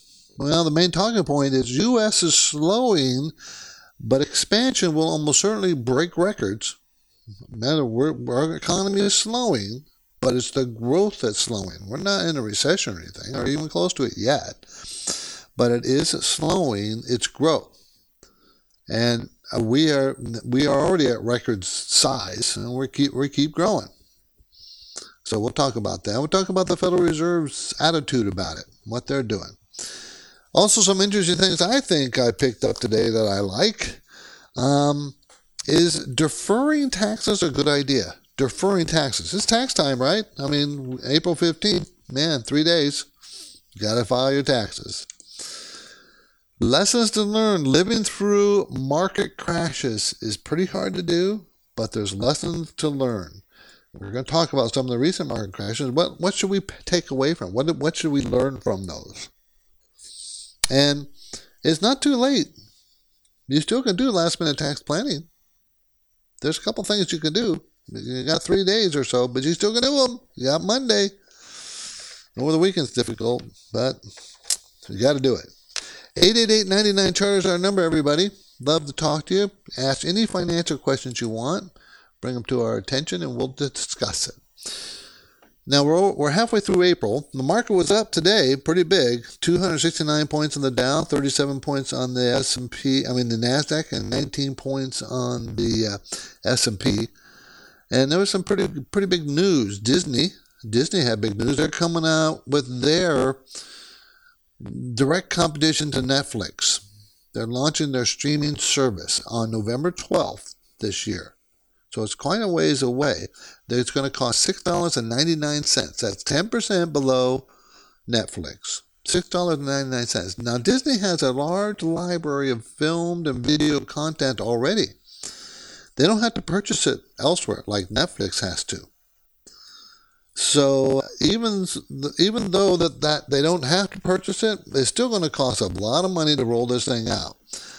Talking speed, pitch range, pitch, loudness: 155 wpm, 125-180 Hz, 145 Hz, -22 LUFS